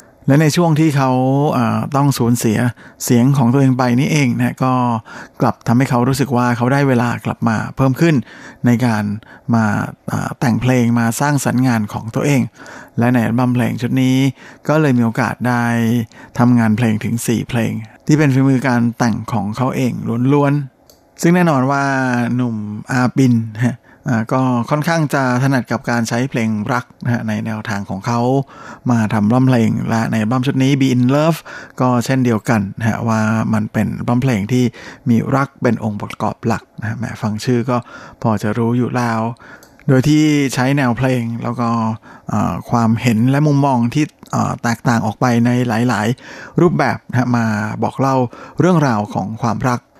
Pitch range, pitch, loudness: 115-135 Hz, 120 Hz, -16 LUFS